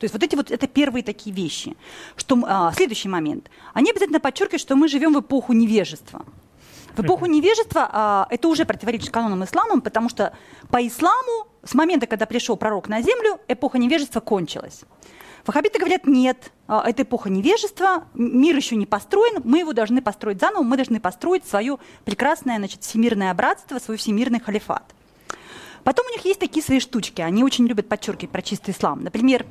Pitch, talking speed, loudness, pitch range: 245 Hz, 175 wpm, -21 LUFS, 215-315 Hz